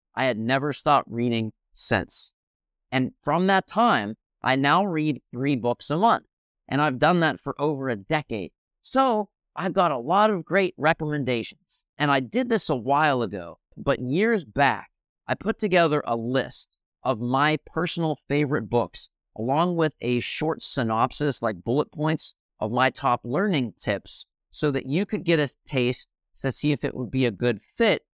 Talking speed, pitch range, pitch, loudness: 175 wpm, 125-160 Hz, 145 Hz, -25 LUFS